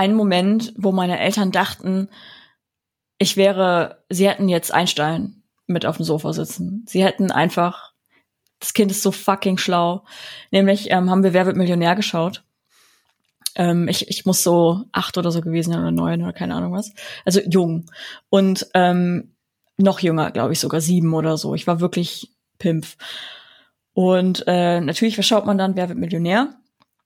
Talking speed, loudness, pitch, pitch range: 170 wpm, -19 LUFS, 185 Hz, 170-195 Hz